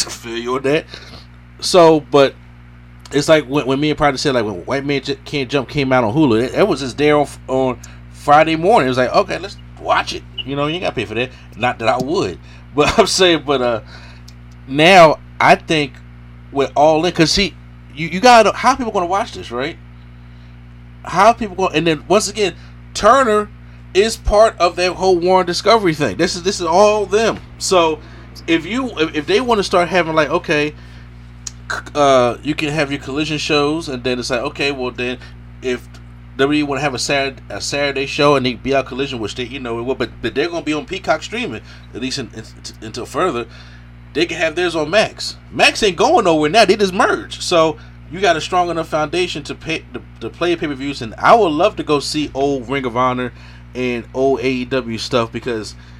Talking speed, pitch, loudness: 215 wpm, 135 Hz, -16 LUFS